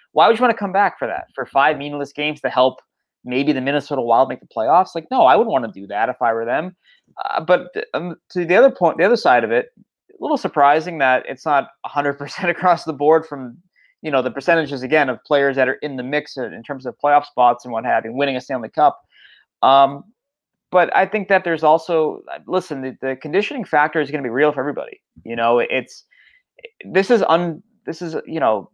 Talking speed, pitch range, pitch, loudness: 235 wpm, 135-185 Hz, 150 Hz, -18 LUFS